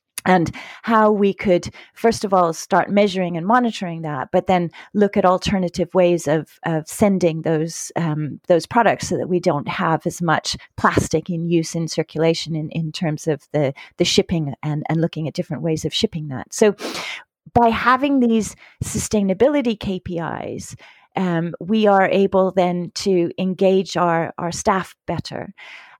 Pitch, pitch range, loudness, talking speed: 175 Hz, 160-195 Hz, -19 LUFS, 160 wpm